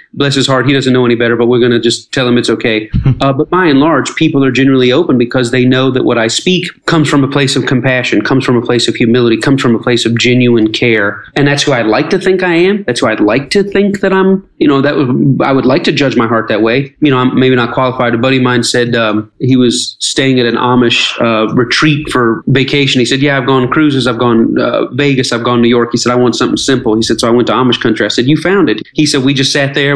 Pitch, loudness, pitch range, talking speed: 130 Hz, -10 LUFS, 120-140 Hz, 290 wpm